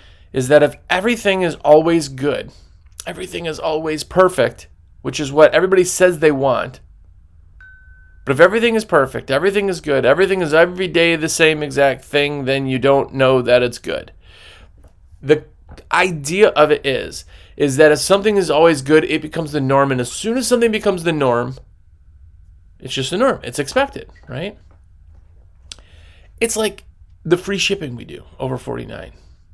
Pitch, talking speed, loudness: 145 Hz, 165 wpm, -16 LUFS